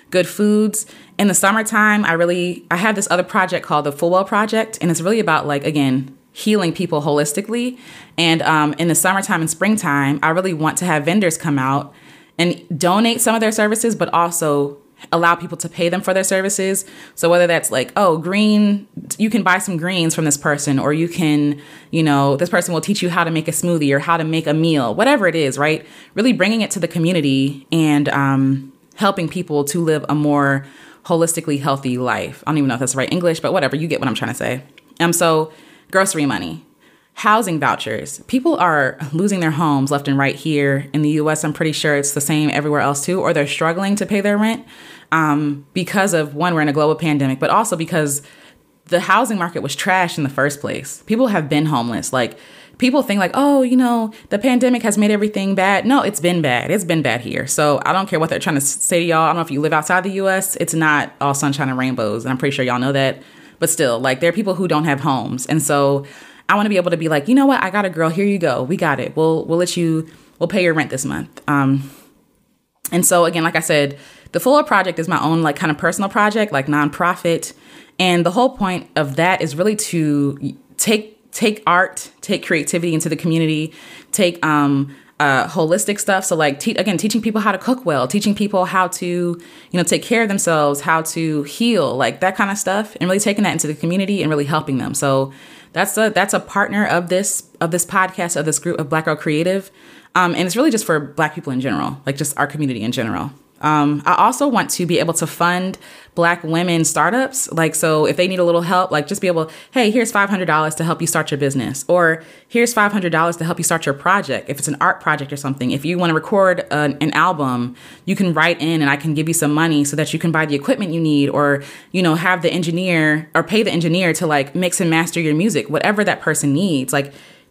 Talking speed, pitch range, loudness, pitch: 235 wpm, 150-190 Hz, -17 LUFS, 165 Hz